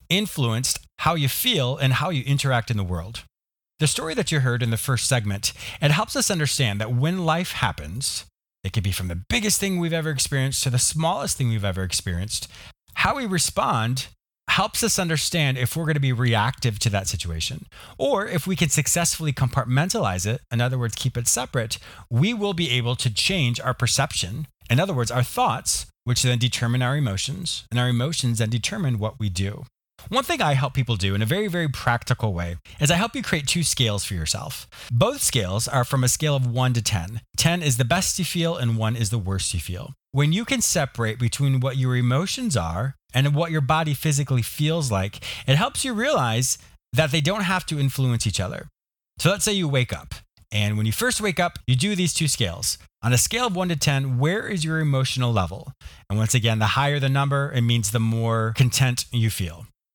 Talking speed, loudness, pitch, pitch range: 215 wpm, -23 LUFS, 130 Hz, 115-155 Hz